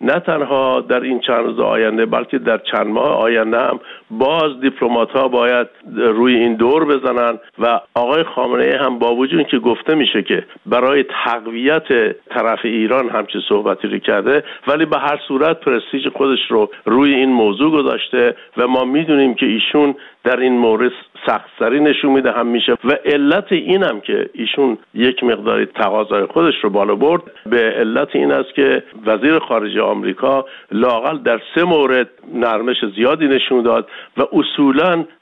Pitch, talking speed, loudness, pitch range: 125 Hz, 160 wpm, -15 LUFS, 115-140 Hz